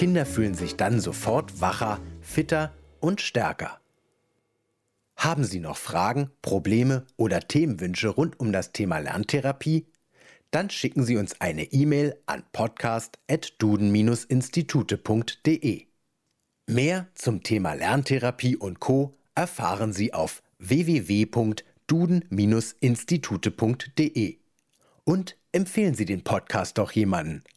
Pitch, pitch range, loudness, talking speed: 125 Hz, 105-150 Hz, -26 LUFS, 100 wpm